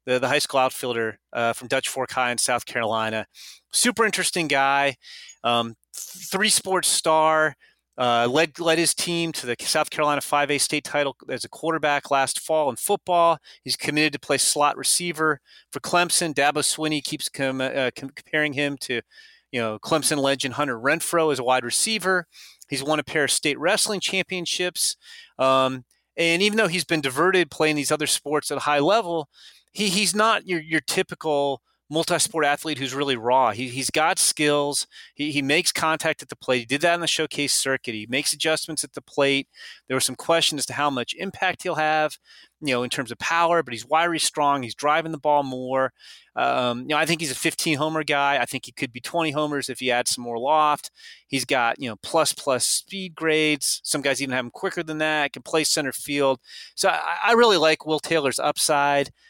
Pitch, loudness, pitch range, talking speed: 150 Hz, -22 LUFS, 135-165 Hz, 205 wpm